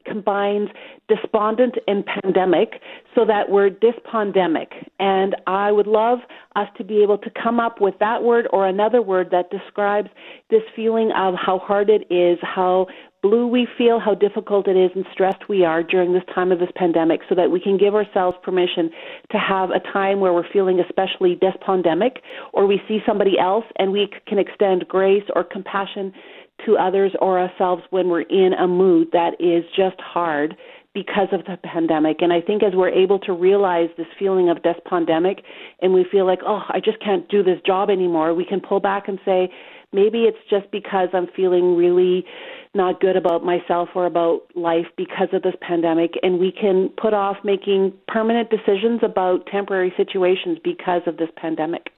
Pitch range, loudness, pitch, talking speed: 180-205 Hz, -19 LUFS, 190 Hz, 185 wpm